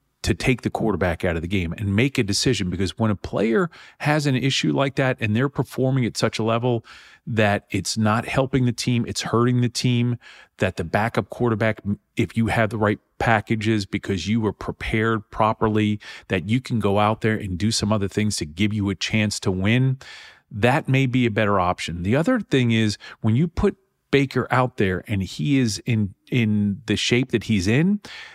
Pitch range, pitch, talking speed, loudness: 105-125 Hz, 110 Hz, 205 wpm, -22 LUFS